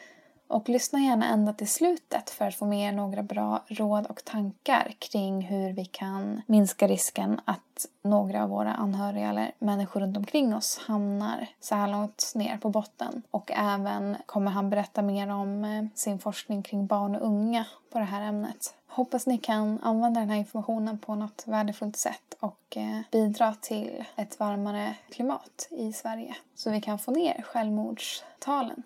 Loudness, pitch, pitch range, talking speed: -29 LUFS, 210 Hz, 205-225 Hz, 170 wpm